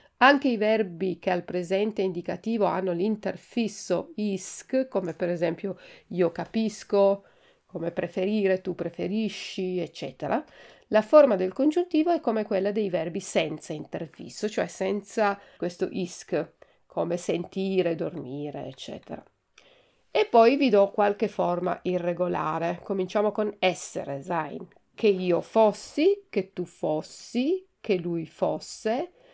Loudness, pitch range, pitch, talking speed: -27 LUFS, 180-220 Hz, 195 Hz, 120 wpm